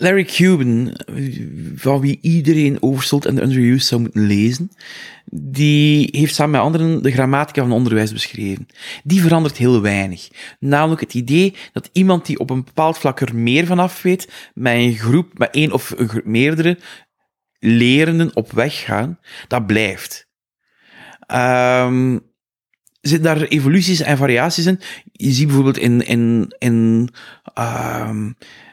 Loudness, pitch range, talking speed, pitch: -16 LUFS, 120-160 Hz, 145 wpm, 135 Hz